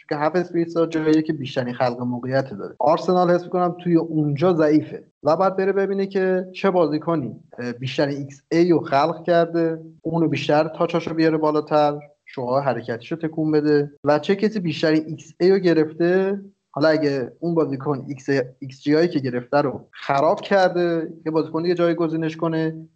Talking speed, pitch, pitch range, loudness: 165 wpm, 160 Hz, 145-170 Hz, -21 LUFS